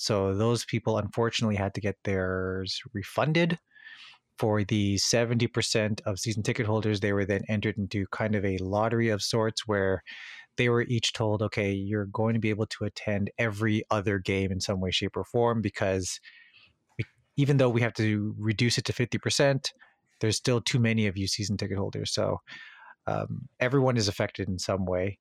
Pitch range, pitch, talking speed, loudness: 100-115 Hz, 110 Hz, 180 wpm, -28 LUFS